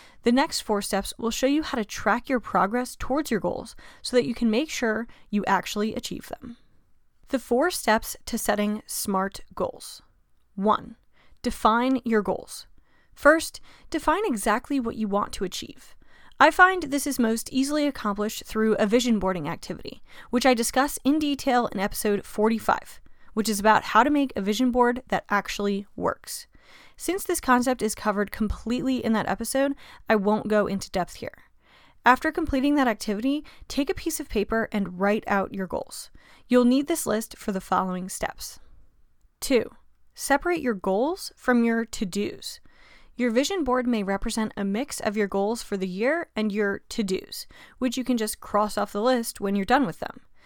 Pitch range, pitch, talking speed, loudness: 205-260 Hz, 230 Hz, 180 wpm, -25 LUFS